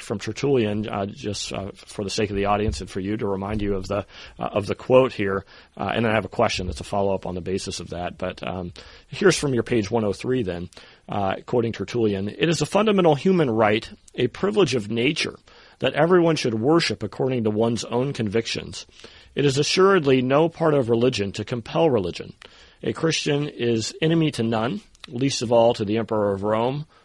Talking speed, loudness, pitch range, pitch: 205 wpm, -23 LUFS, 100-135 Hz, 115 Hz